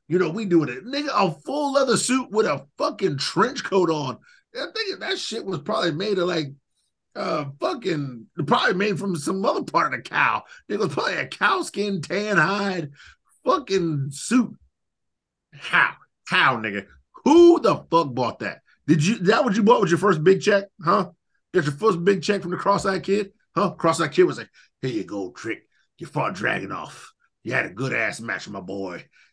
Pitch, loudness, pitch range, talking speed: 195 Hz, -22 LUFS, 165-220 Hz, 200 wpm